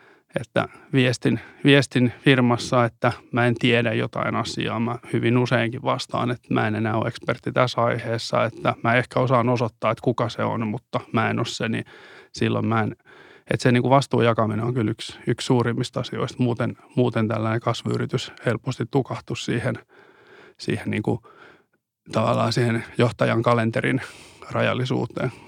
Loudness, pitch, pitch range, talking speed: -23 LUFS, 120 Hz, 115-125 Hz, 160 wpm